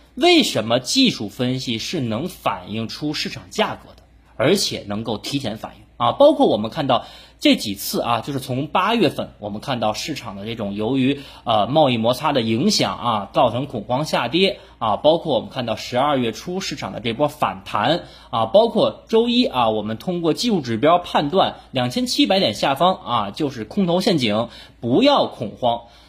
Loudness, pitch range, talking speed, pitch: -20 LUFS, 110-185 Hz, 275 characters per minute, 135 Hz